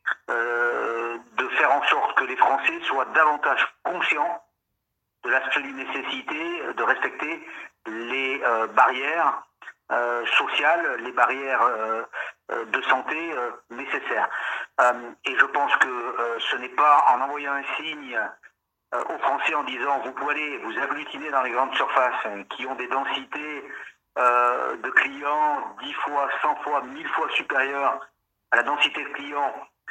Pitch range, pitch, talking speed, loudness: 115-135 Hz, 120 Hz, 150 wpm, -24 LUFS